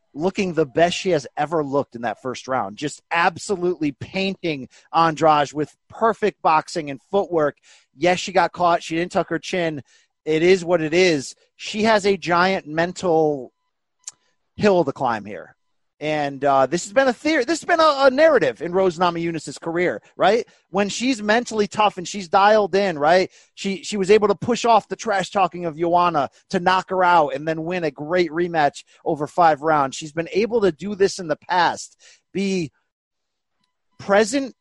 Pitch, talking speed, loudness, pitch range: 175 Hz, 185 wpm, -20 LUFS, 155-200 Hz